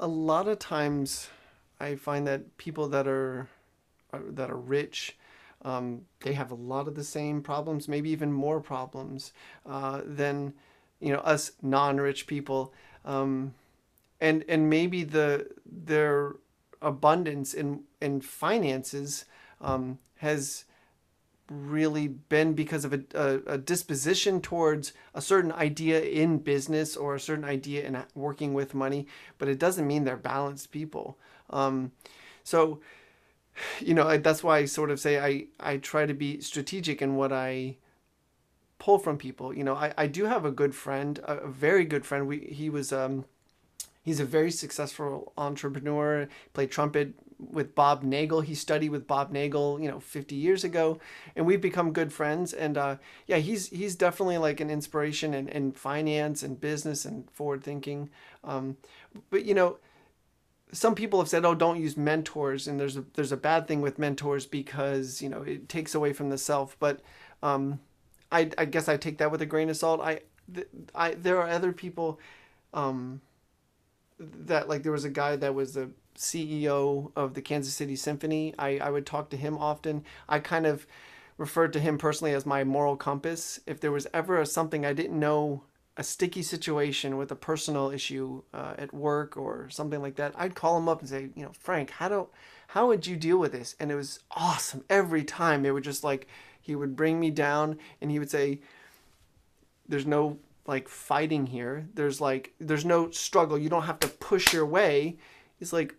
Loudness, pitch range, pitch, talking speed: -29 LUFS, 140-155 Hz, 145 Hz, 180 wpm